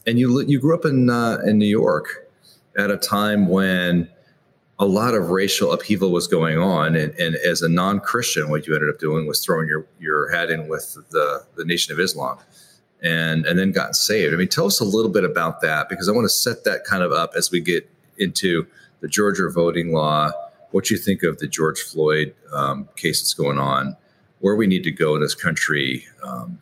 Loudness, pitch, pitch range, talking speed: -20 LUFS, 85 Hz, 75-105 Hz, 215 wpm